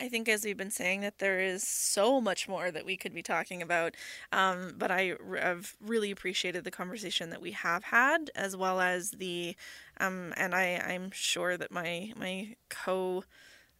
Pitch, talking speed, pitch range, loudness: 185 Hz, 185 wpm, 180-205 Hz, -32 LUFS